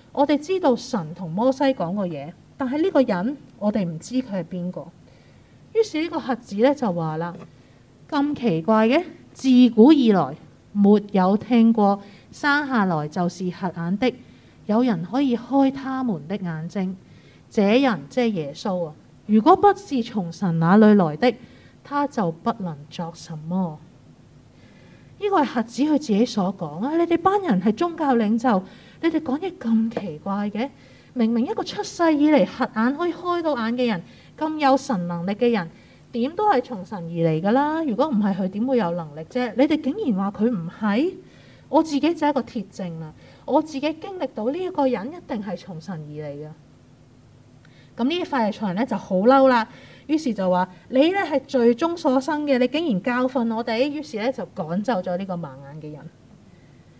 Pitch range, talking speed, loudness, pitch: 185-275 Hz, 255 characters per minute, -22 LUFS, 230 Hz